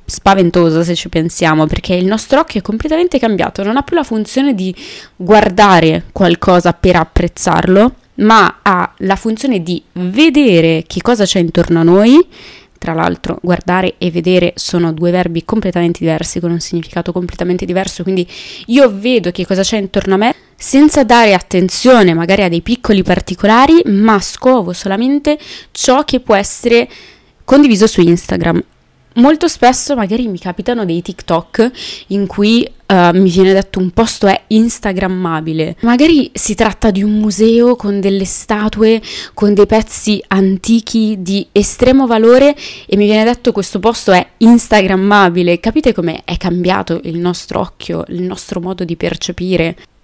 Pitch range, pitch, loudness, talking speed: 180-230 Hz, 195 Hz, -11 LUFS, 155 wpm